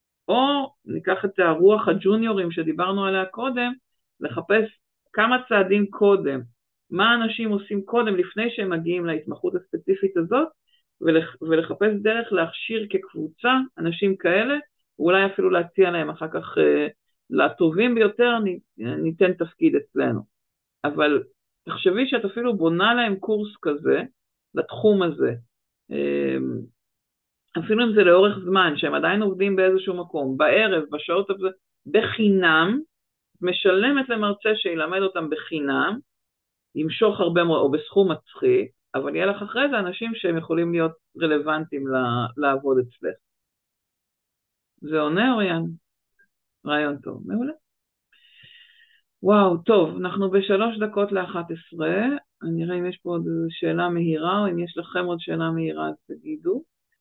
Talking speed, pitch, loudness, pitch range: 125 wpm, 190 Hz, -22 LUFS, 165-225 Hz